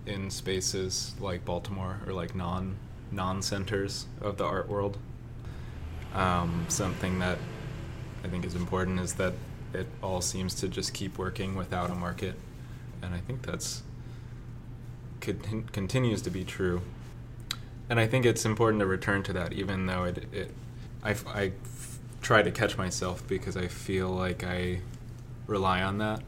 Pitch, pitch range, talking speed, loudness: 100 Hz, 95-120 Hz, 160 wpm, -32 LUFS